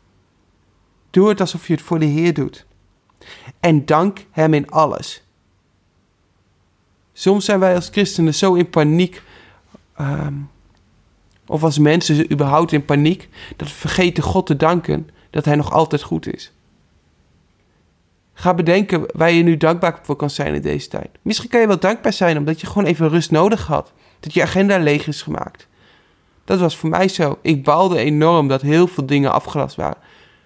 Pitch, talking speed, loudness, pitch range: 155 Hz, 170 wpm, -17 LUFS, 105-175 Hz